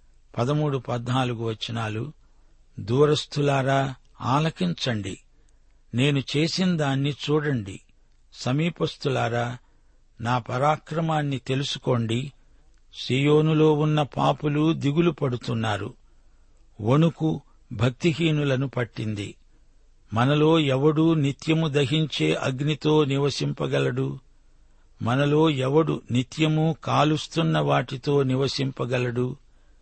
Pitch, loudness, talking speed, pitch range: 135 Hz, -24 LUFS, 65 wpm, 120-150 Hz